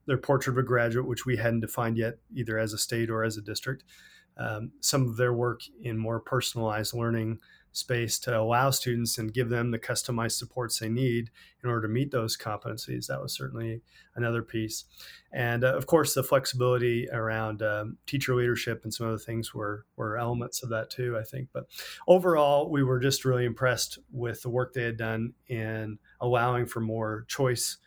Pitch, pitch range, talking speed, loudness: 120 Hz, 110-125 Hz, 195 wpm, -29 LUFS